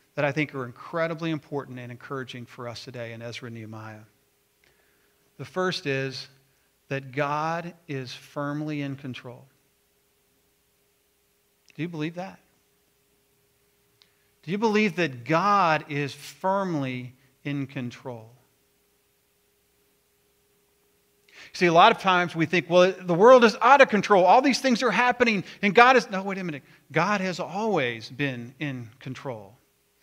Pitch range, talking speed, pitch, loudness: 130-180 Hz, 140 wpm, 145 Hz, -23 LUFS